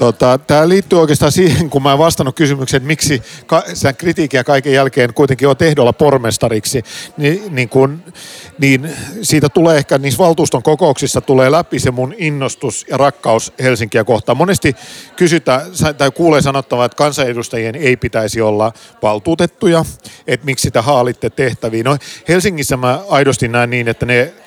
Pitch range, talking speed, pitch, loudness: 125-155 Hz, 155 wpm, 140 Hz, -13 LUFS